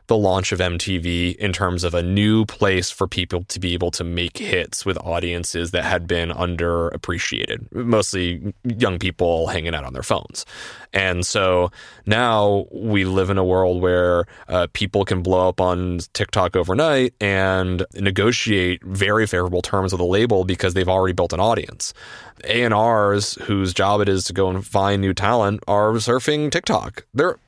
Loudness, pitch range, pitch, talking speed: -20 LUFS, 90-100 Hz, 95 Hz, 170 wpm